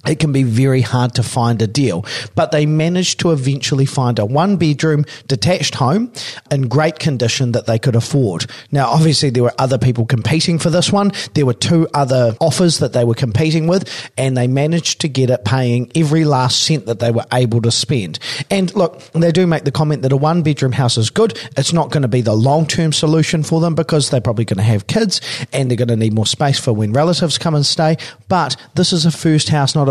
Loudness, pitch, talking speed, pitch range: -15 LUFS, 145 Hz, 235 wpm, 125-160 Hz